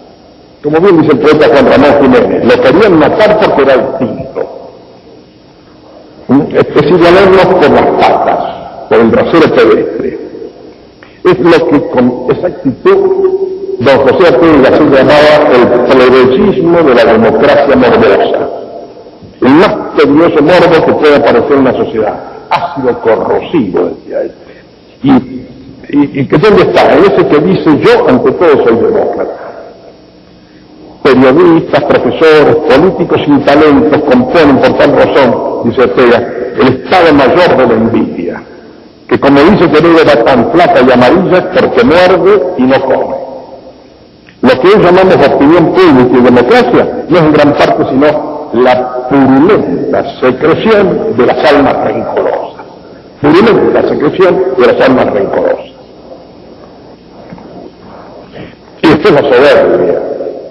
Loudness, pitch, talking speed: -6 LUFS, 185 Hz, 140 wpm